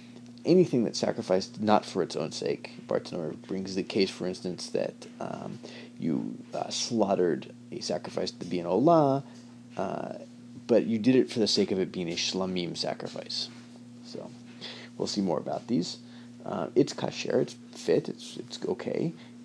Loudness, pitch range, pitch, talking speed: -29 LUFS, 115-120 Hz, 120 Hz, 165 wpm